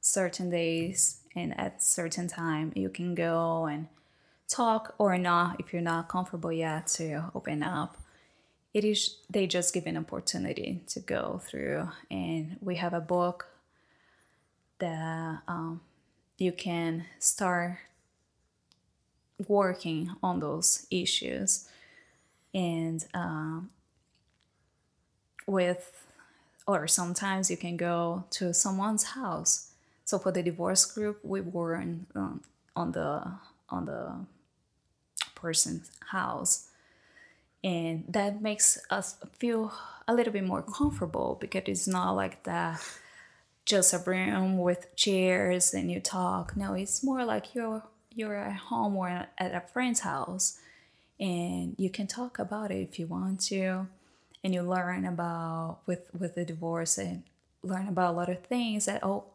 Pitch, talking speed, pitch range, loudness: 180 Hz, 135 wpm, 170-195 Hz, -30 LUFS